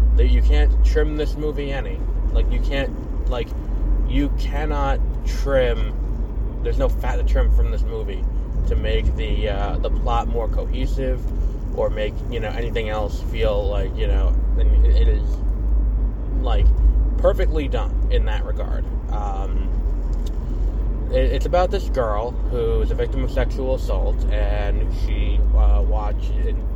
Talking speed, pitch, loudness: 150 wpm, 85 Hz, -22 LUFS